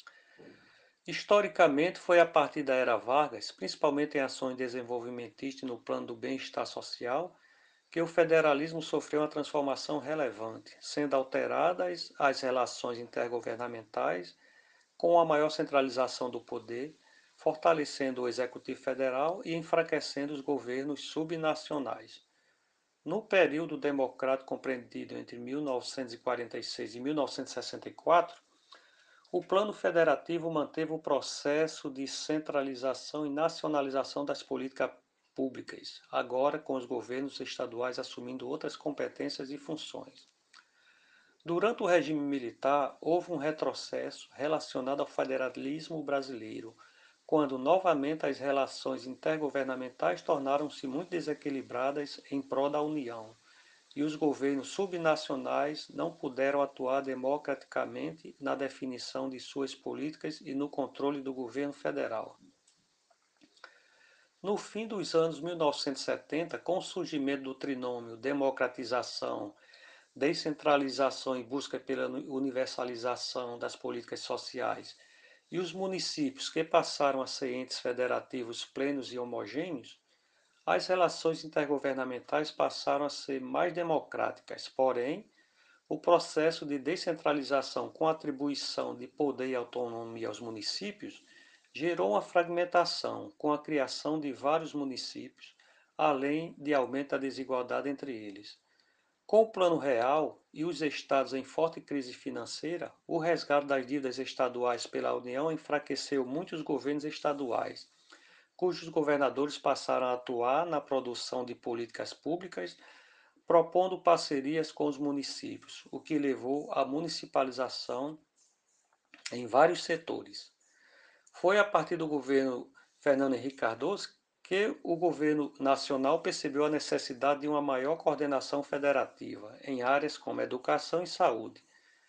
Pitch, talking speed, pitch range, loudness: 140 Hz, 115 wpm, 130-160 Hz, -33 LUFS